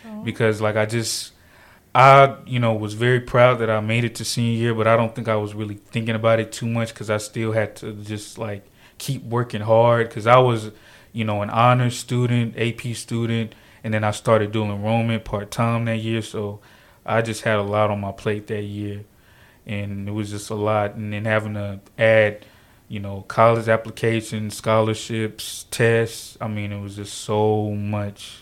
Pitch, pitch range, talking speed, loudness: 110 Hz, 105-115 Hz, 200 wpm, -21 LUFS